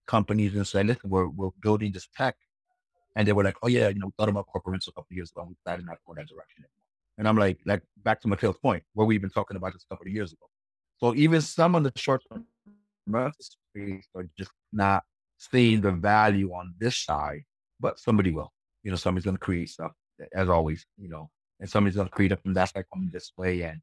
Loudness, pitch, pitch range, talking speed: -27 LUFS, 100 Hz, 95-110 Hz, 245 wpm